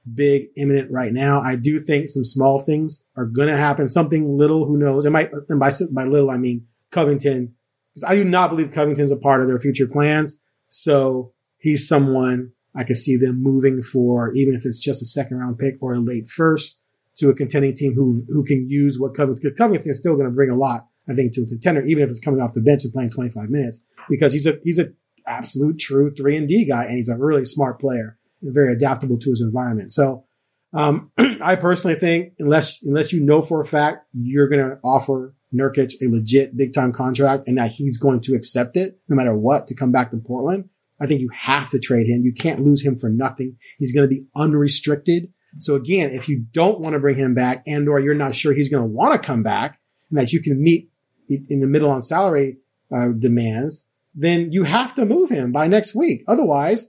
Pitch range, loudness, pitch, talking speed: 130-150 Hz, -19 LUFS, 140 Hz, 225 wpm